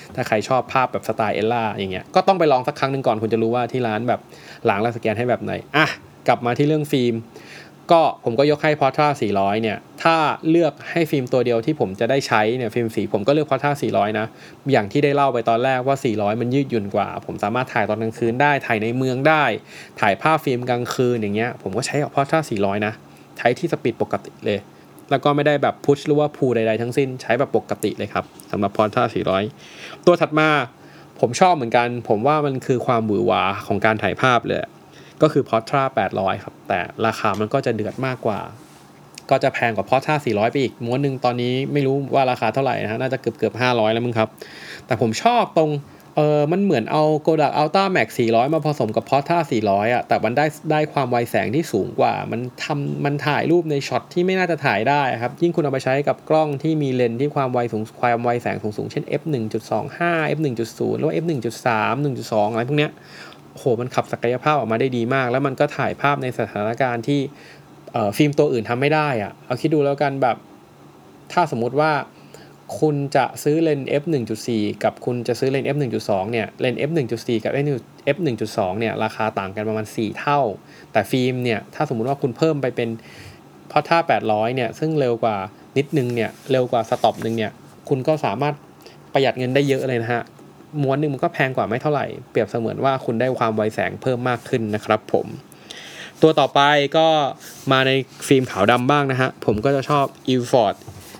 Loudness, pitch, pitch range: -20 LUFS, 130 Hz, 115-145 Hz